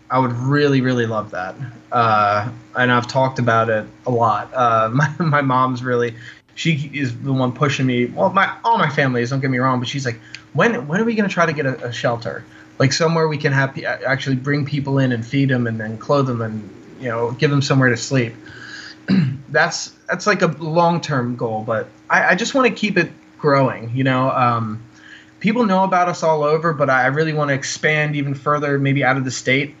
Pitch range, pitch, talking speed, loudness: 120-155 Hz, 135 Hz, 225 wpm, -18 LUFS